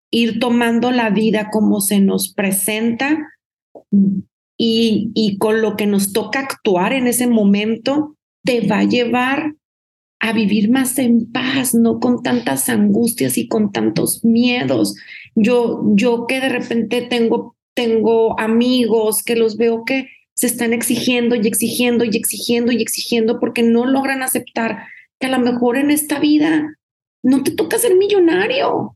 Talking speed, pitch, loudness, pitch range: 150 wpm, 235 Hz, -16 LUFS, 225-255 Hz